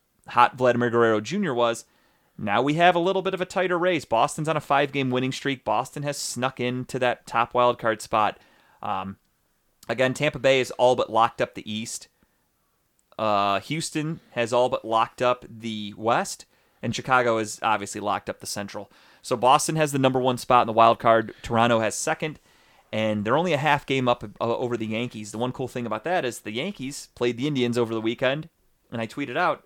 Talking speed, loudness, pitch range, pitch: 205 wpm, -24 LUFS, 115-140 Hz, 125 Hz